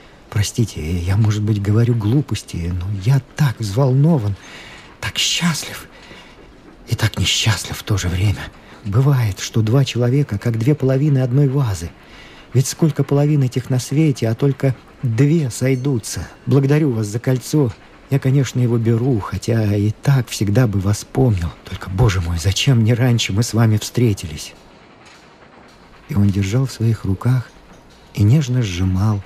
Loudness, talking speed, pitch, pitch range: -18 LUFS, 150 wpm, 120 Hz, 100-135 Hz